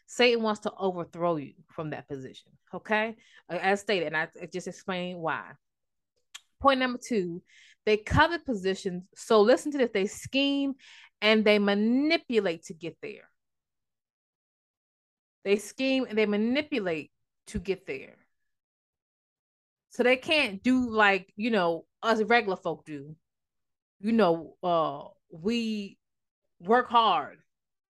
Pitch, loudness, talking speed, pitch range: 210 Hz, -27 LUFS, 130 wpm, 175-240 Hz